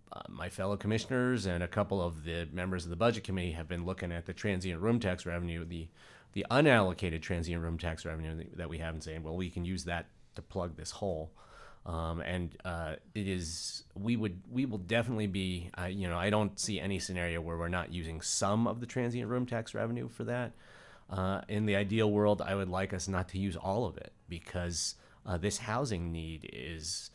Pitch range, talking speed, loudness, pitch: 85-105 Hz, 215 wpm, -35 LUFS, 95 Hz